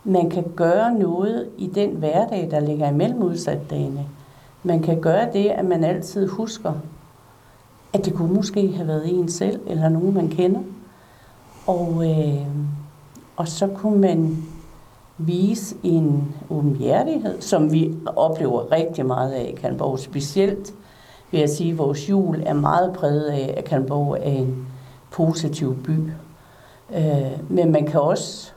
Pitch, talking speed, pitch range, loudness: 160 Hz, 145 wpm, 140-180 Hz, -21 LUFS